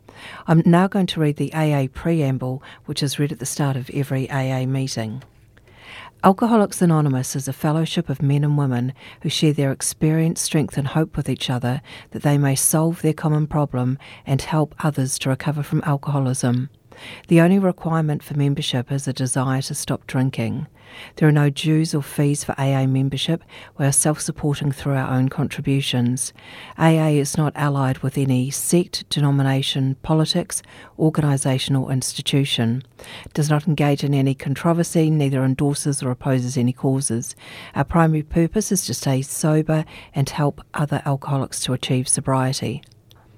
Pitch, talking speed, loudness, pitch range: 140 Hz, 165 wpm, -20 LUFS, 130-155 Hz